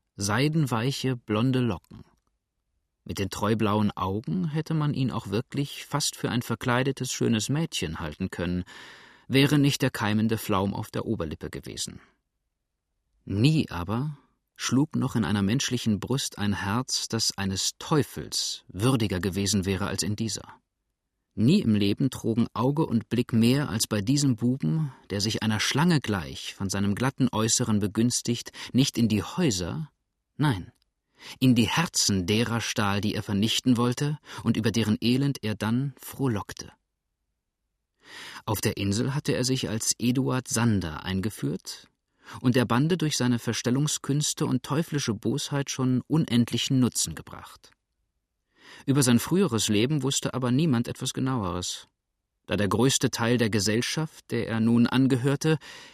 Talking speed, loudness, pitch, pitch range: 145 wpm, -26 LUFS, 120 Hz, 105-135 Hz